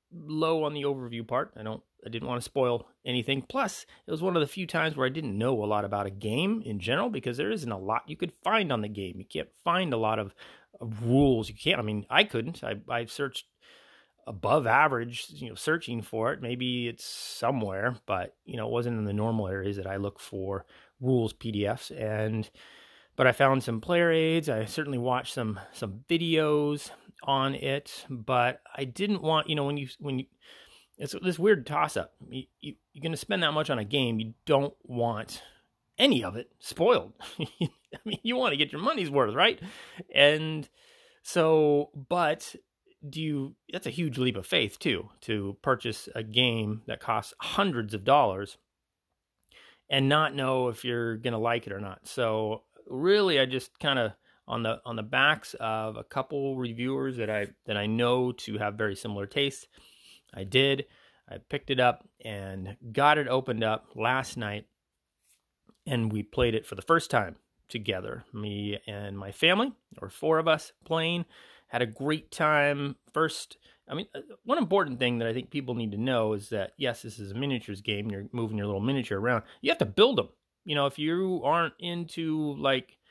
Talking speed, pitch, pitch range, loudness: 195 wpm, 125 Hz, 110-150 Hz, -29 LUFS